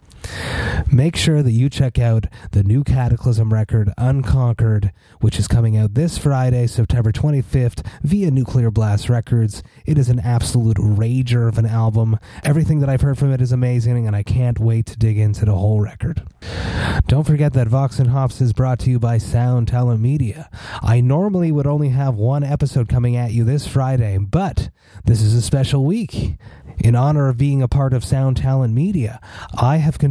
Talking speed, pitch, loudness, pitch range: 185 wpm, 120 Hz, -17 LUFS, 110-135 Hz